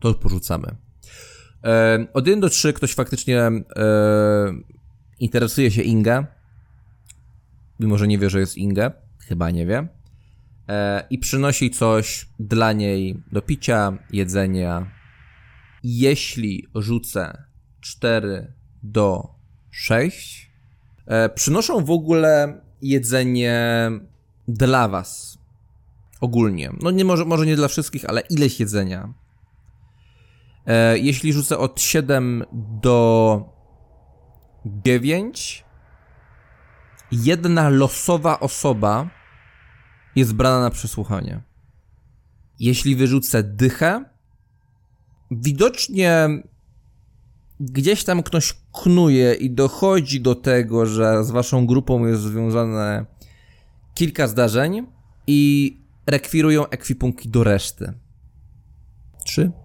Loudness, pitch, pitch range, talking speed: -19 LUFS, 120 Hz, 110-135 Hz, 95 wpm